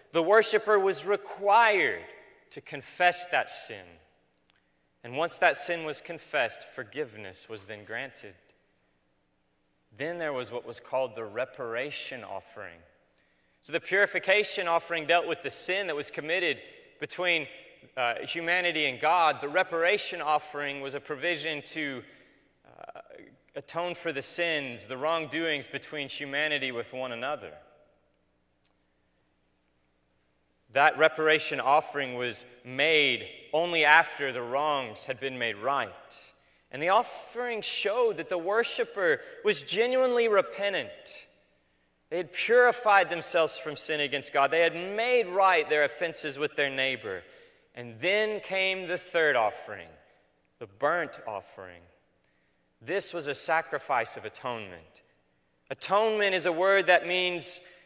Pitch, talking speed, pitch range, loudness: 155 Hz, 130 wpm, 125-180 Hz, -27 LUFS